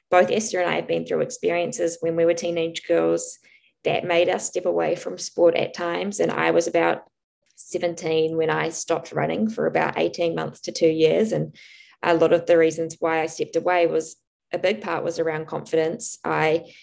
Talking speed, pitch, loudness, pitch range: 200 wpm, 165 Hz, -23 LUFS, 160-175 Hz